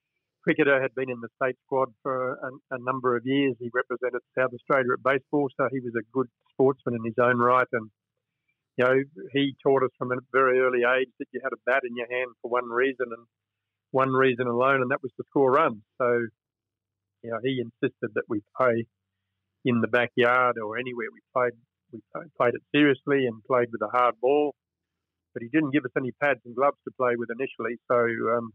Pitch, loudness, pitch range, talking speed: 125 Hz, -26 LUFS, 120-135 Hz, 210 wpm